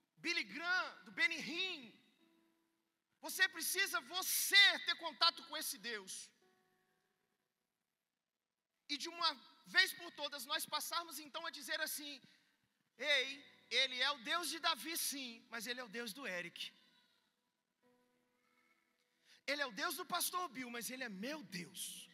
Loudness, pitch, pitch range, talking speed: -38 LUFS, 275 Hz, 235-330 Hz, 140 wpm